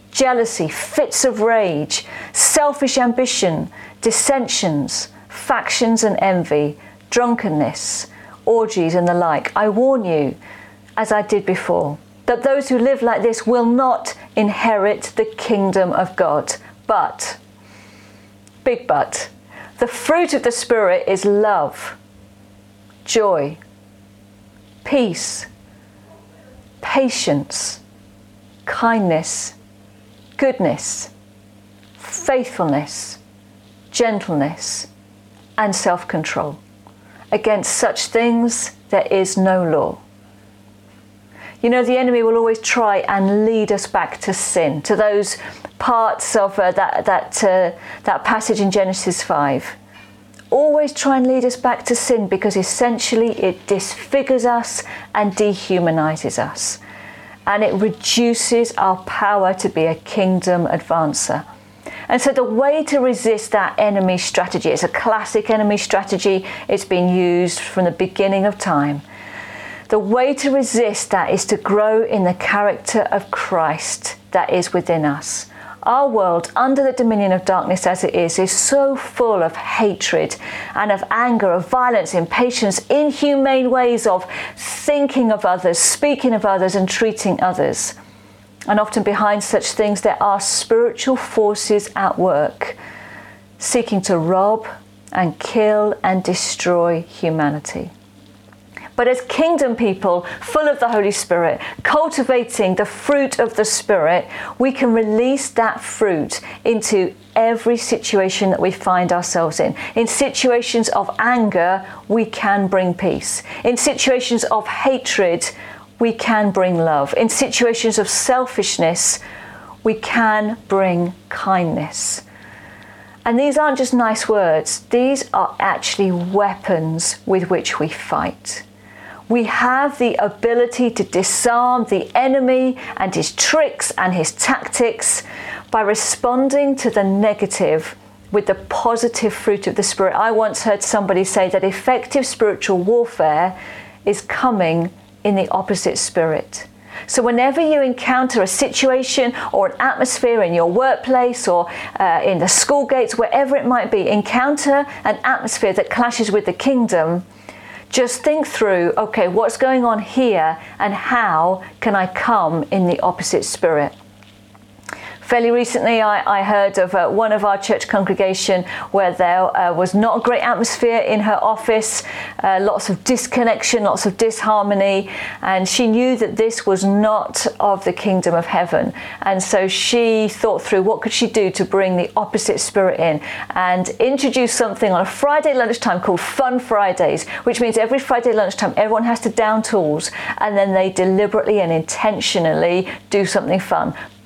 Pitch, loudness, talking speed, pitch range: 205 Hz, -17 LUFS, 135 wpm, 175-240 Hz